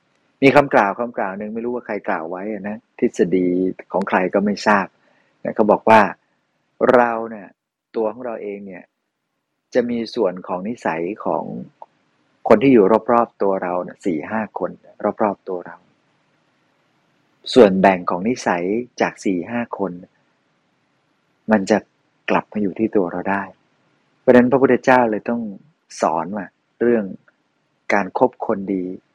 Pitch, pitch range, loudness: 105 Hz, 95-115 Hz, -19 LUFS